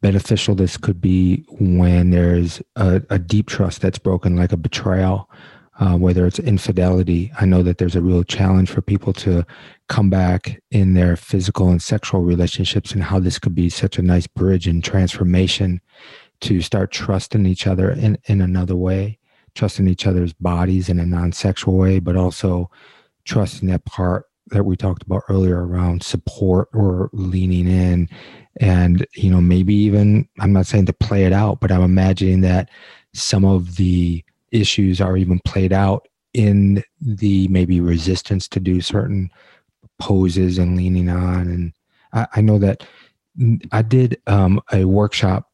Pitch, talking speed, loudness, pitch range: 95 Hz, 165 wpm, -17 LUFS, 90-100 Hz